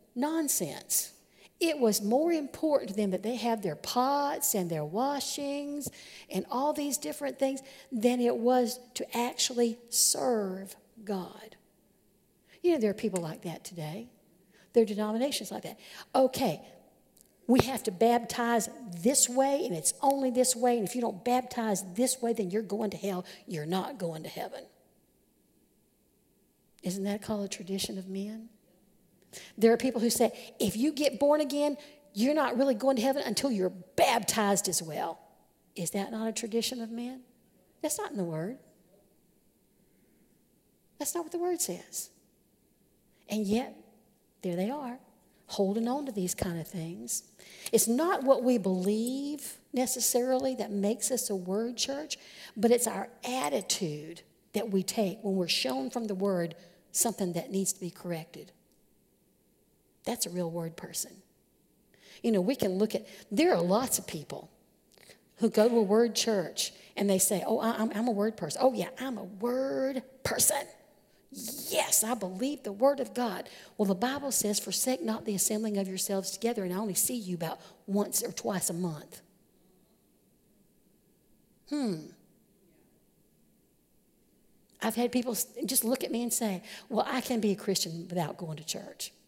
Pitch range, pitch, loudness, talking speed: 195-255 Hz, 225 Hz, -30 LUFS, 165 wpm